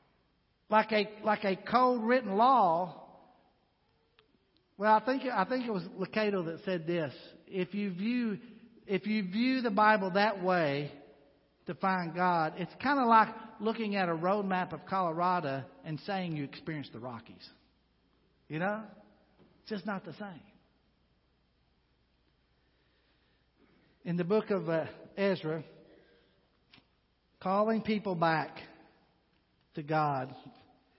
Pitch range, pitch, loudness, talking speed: 155-210 Hz, 185 Hz, -31 LUFS, 130 wpm